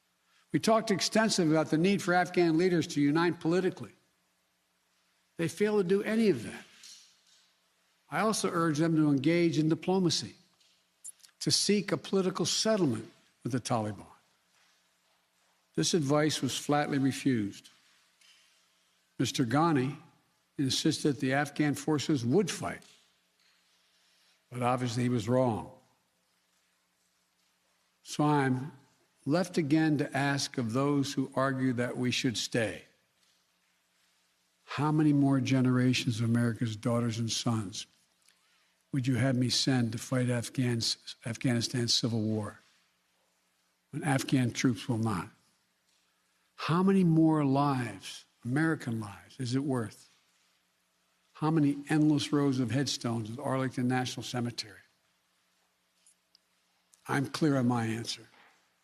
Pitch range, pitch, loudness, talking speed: 120-155 Hz, 135 Hz, -30 LUFS, 120 wpm